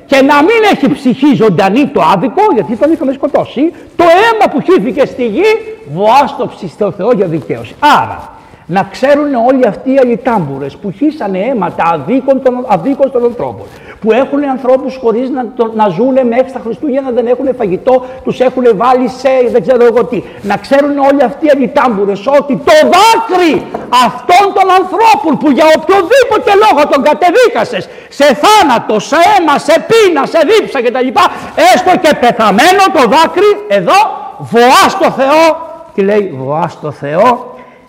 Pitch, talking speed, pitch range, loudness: 270 Hz, 160 wpm, 235-325 Hz, -9 LUFS